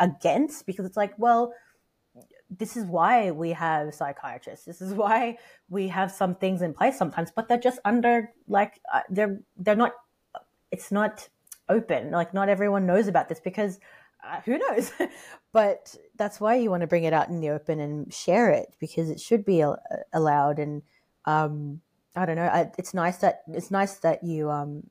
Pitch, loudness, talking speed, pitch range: 190 Hz, -26 LUFS, 190 wpm, 165-215 Hz